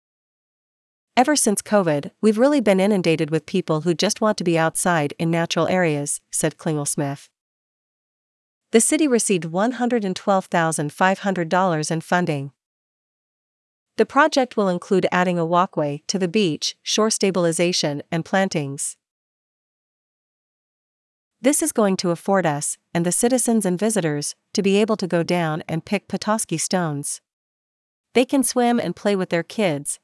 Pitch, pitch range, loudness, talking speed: 180 Hz, 160-210 Hz, -20 LUFS, 140 wpm